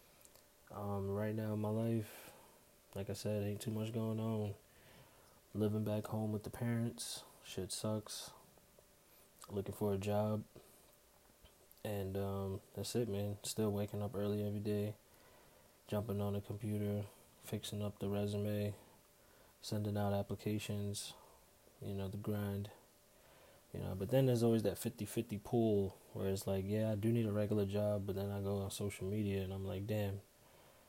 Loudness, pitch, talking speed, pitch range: -40 LUFS, 105 Hz, 160 wpm, 100-110 Hz